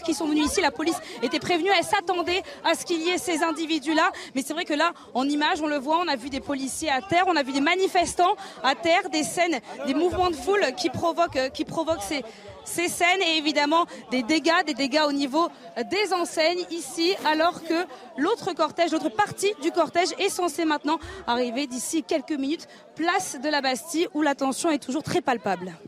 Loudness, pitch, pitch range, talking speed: -25 LUFS, 325 Hz, 290-350 Hz, 215 wpm